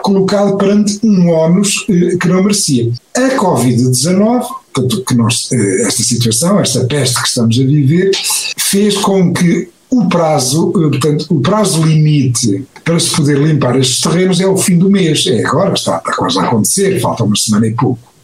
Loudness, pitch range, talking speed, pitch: -11 LUFS, 130-195 Hz, 180 wpm, 165 Hz